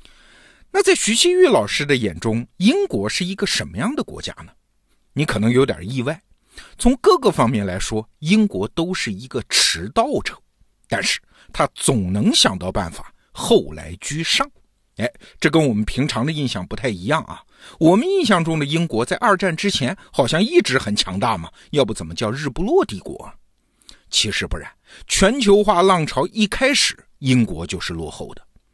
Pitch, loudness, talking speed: 155 Hz, -19 LUFS, 255 characters per minute